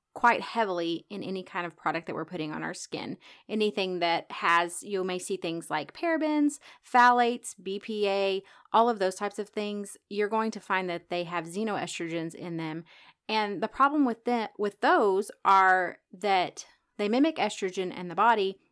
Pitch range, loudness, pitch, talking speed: 180-220 Hz, -28 LUFS, 200 Hz, 175 wpm